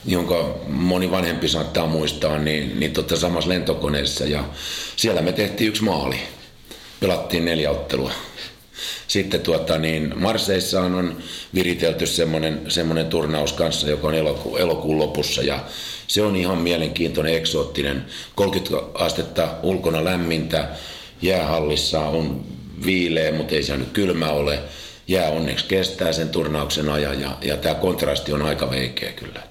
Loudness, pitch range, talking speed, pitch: -22 LUFS, 75-90 Hz, 135 wpm, 80 Hz